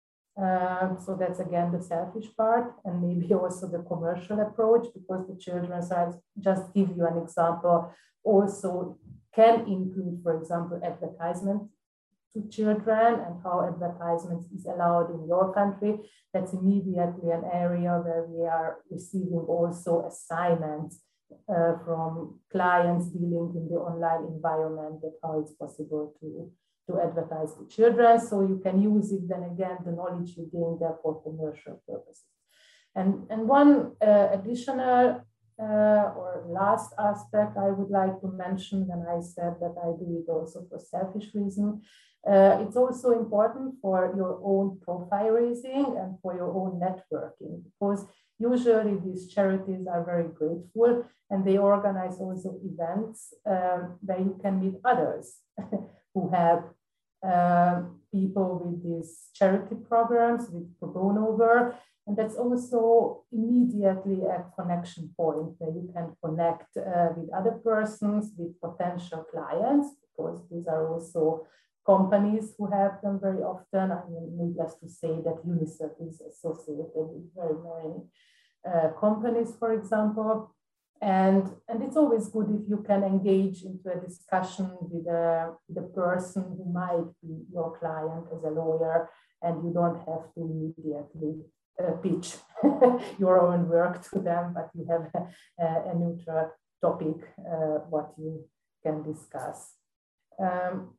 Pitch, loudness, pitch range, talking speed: 180 Hz, -28 LUFS, 170-200 Hz, 145 wpm